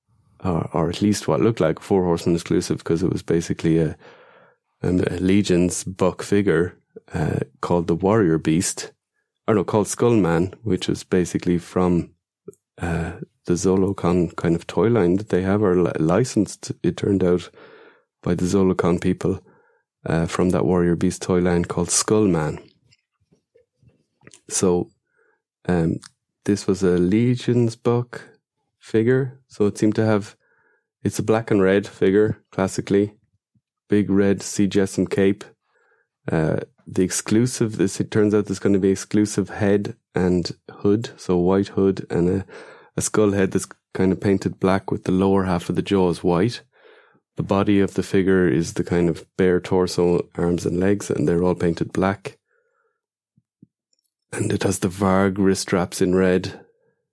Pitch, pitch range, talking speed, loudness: 95 Hz, 90-105 Hz, 160 wpm, -21 LUFS